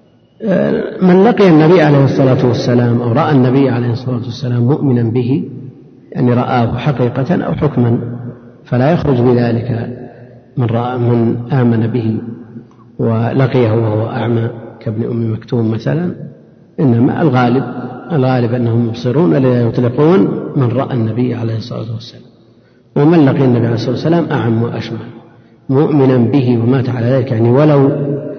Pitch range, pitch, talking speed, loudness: 115-135 Hz, 125 Hz, 130 wpm, -13 LUFS